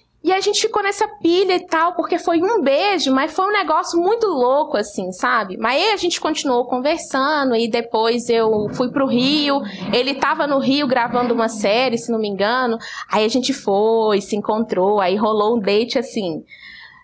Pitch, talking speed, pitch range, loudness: 255 Hz, 190 wpm, 225-335 Hz, -18 LUFS